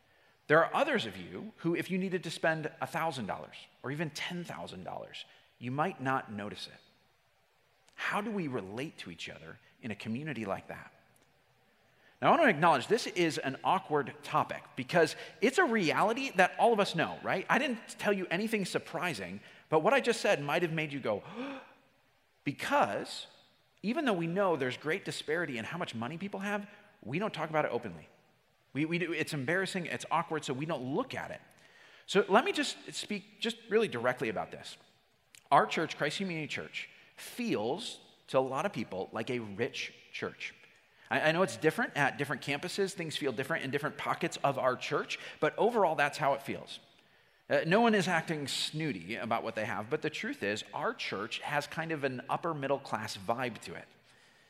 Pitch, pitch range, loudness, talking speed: 160 Hz, 140-195 Hz, -33 LUFS, 195 wpm